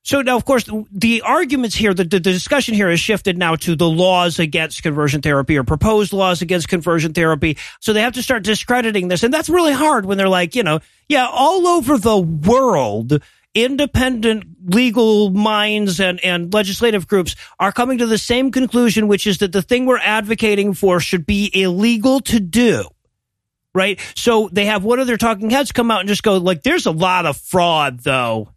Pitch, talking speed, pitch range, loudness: 205 Hz, 195 wpm, 180-235 Hz, -16 LUFS